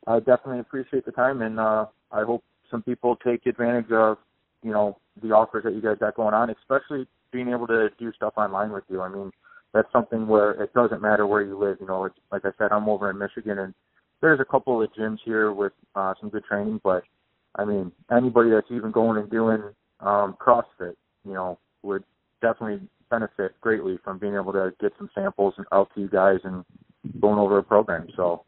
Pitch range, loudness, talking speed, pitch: 100-115 Hz, -24 LUFS, 210 wpm, 105 Hz